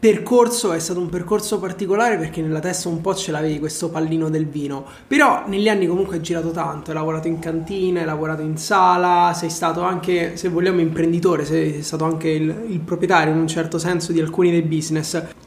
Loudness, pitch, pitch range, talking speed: -20 LUFS, 170 Hz, 160-185 Hz, 200 wpm